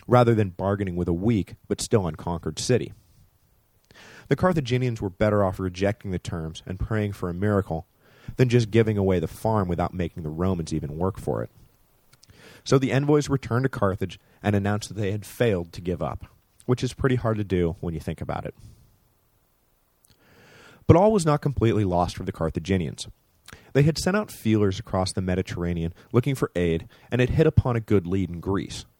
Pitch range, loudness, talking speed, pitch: 90-120 Hz, -25 LUFS, 190 wpm, 105 Hz